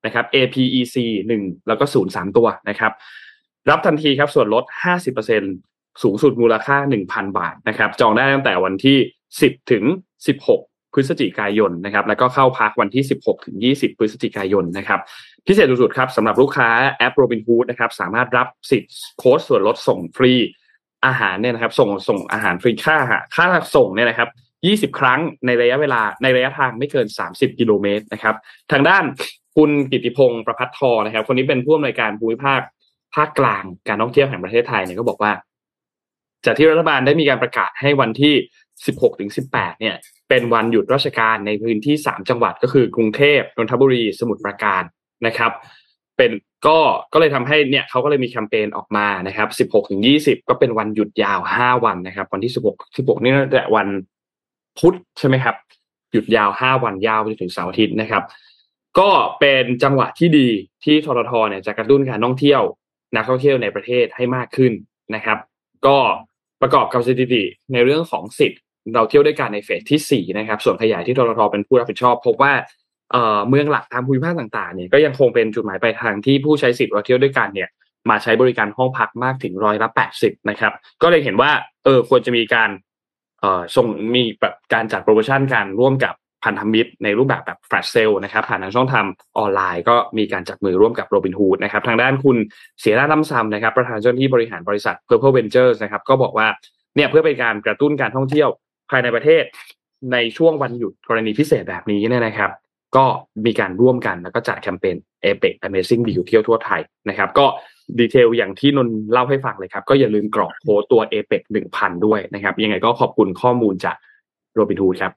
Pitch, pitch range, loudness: 120 Hz, 110-135 Hz, -17 LUFS